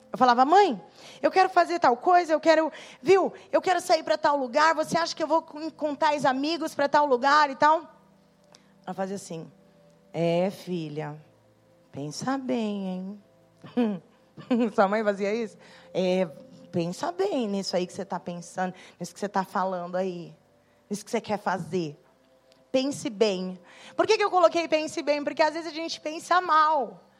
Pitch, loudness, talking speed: 230 Hz, -25 LUFS, 170 wpm